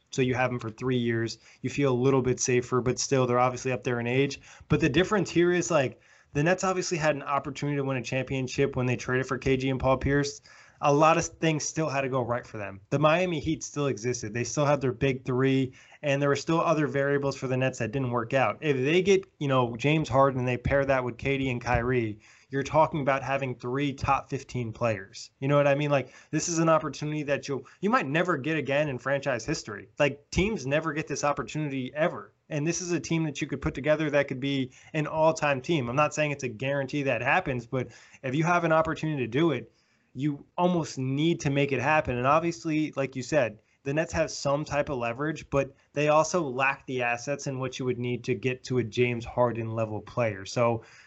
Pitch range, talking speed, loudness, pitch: 125-150 Hz, 235 wpm, -27 LUFS, 140 Hz